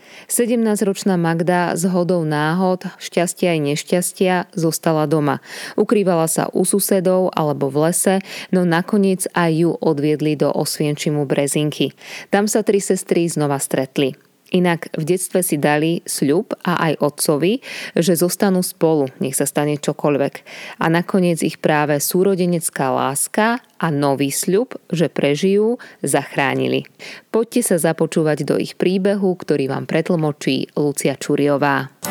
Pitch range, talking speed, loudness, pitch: 150-185 Hz, 130 wpm, -18 LUFS, 170 Hz